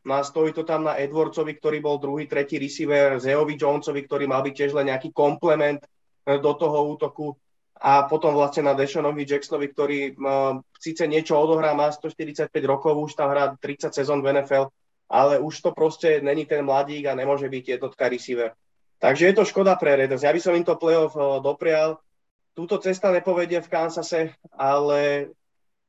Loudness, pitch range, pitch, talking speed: -23 LUFS, 140-160 Hz, 145 Hz, 175 wpm